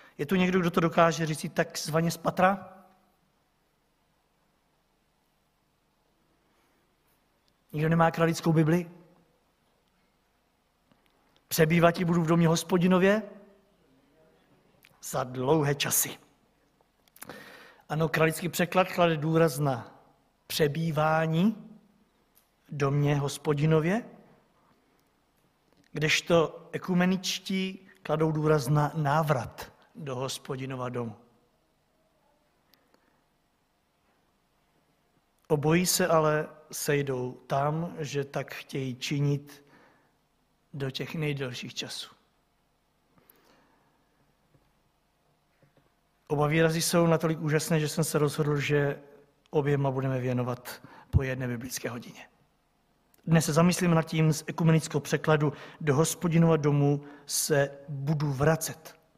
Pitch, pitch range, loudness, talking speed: 160 Hz, 145-170 Hz, -27 LUFS, 90 wpm